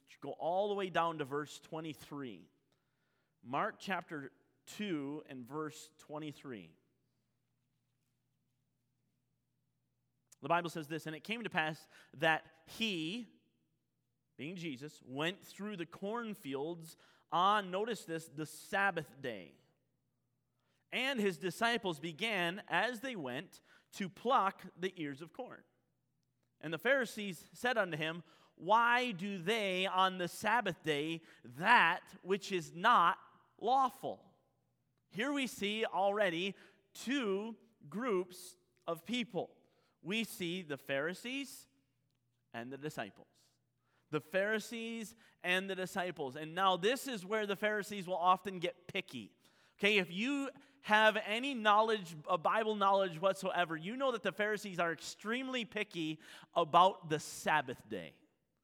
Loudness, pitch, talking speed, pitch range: -36 LUFS, 175 Hz, 125 wpm, 150-210 Hz